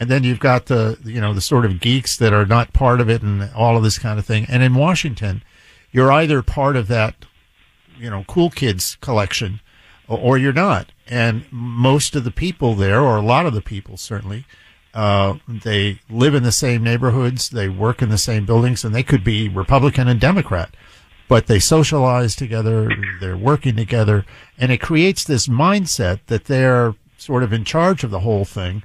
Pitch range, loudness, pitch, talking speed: 105-130 Hz, -17 LUFS, 115 Hz, 200 wpm